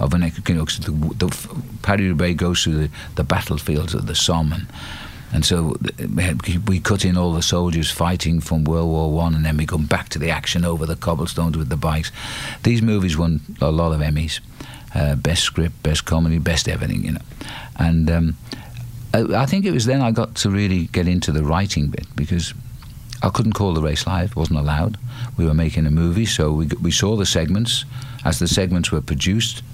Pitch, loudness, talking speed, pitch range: 85 Hz, -20 LUFS, 205 wpm, 80-105 Hz